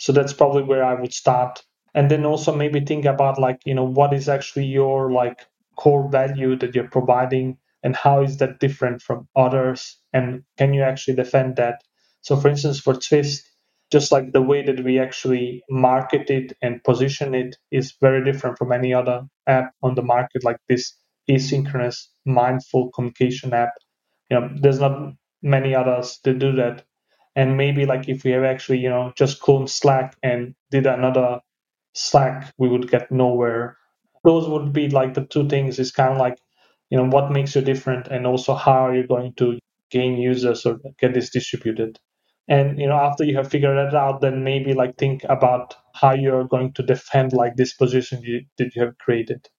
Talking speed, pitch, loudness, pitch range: 190 wpm, 130 Hz, -20 LUFS, 125-140 Hz